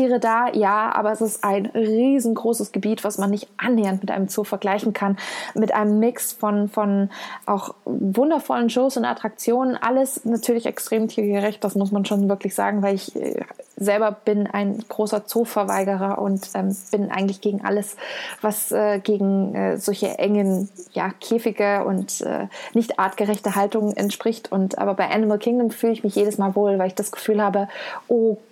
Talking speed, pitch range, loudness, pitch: 170 wpm, 200-225 Hz, -22 LUFS, 210 Hz